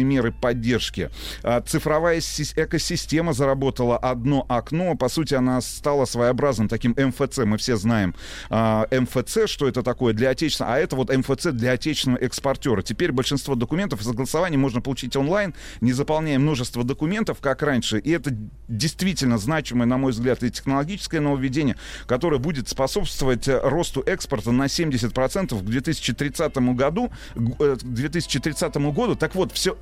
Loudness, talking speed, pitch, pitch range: -23 LUFS, 140 wpm, 135 Hz, 125-155 Hz